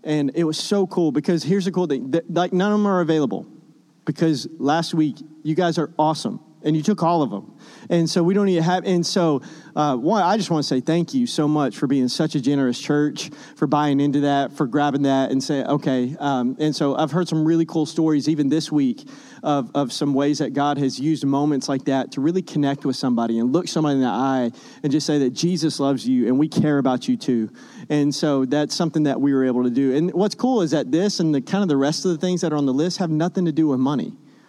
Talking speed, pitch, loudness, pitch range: 255 wpm, 155 Hz, -21 LUFS, 140-170 Hz